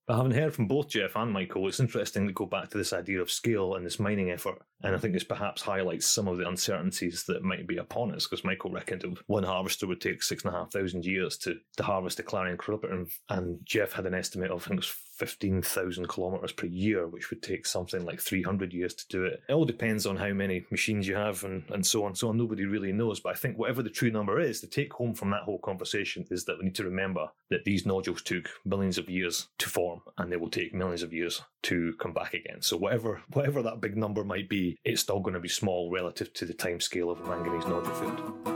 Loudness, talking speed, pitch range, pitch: -31 LUFS, 250 wpm, 90-110 Hz, 95 Hz